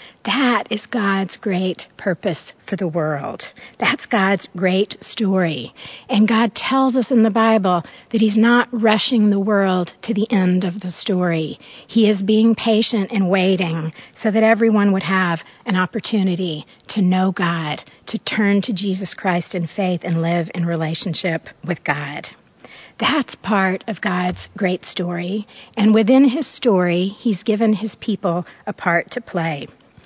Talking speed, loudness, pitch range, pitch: 155 wpm, -19 LUFS, 180-220 Hz, 195 Hz